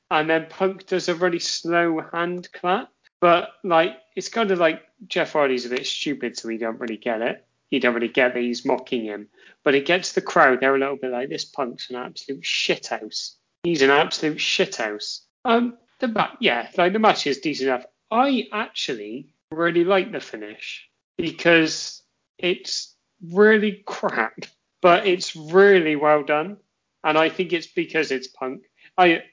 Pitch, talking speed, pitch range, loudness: 170 Hz, 180 wpm, 135-190 Hz, -21 LUFS